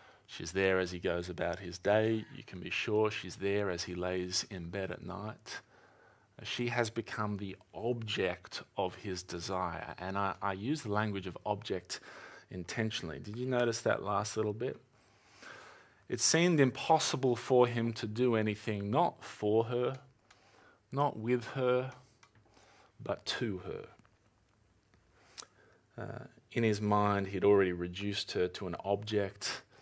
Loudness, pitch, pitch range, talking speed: -34 LUFS, 105 Hz, 95-120 Hz, 145 wpm